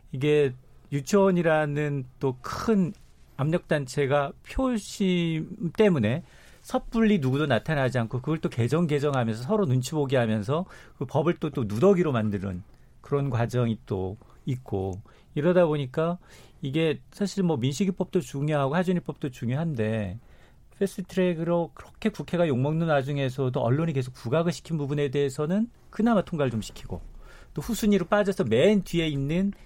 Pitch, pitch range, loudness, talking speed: 150 Hz, 130-175 Hz, -26 LUFS, 330 characters per minute